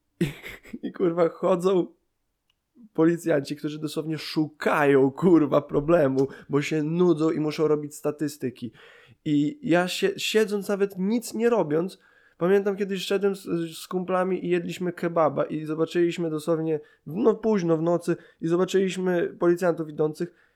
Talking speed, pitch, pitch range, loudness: 130 wpm, 170 Hz, 155-185 Hz, -25 LUFS